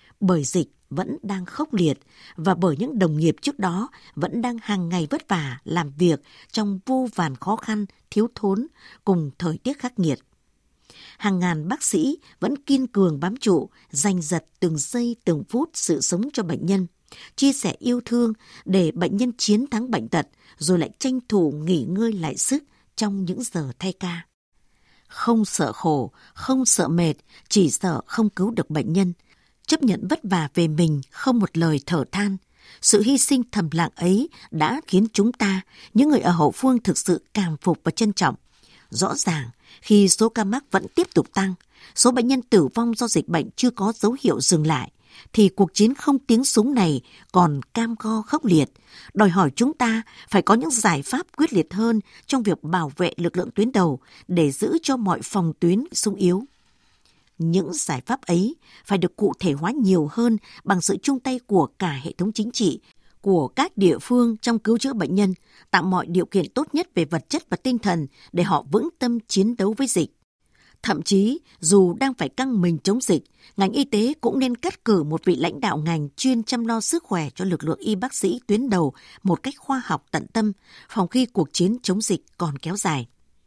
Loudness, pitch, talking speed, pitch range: -22 LUFS, 195 Hz, 205 wpm, 175-235 Hz